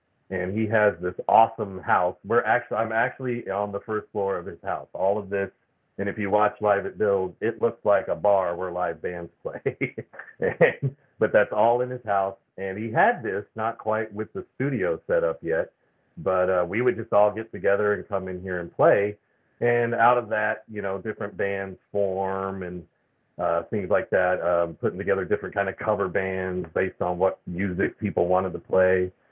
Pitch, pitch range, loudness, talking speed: 100 Hz, 95-110 Hz, -25 LUFS, 205 wpm